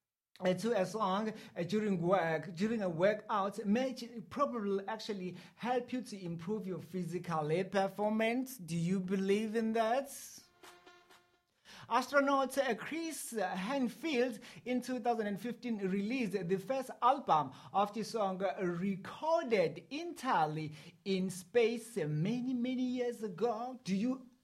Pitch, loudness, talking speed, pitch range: 220 Hz, -35 LUFS, 110 wpm, 190-250 Hz